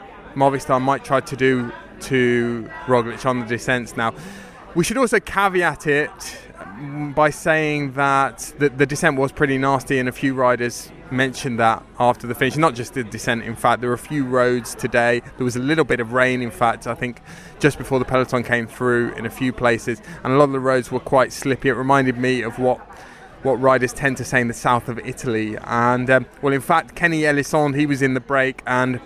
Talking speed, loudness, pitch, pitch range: 215 wpm, -20 LUFS, 130 Hz, 120-140 Hz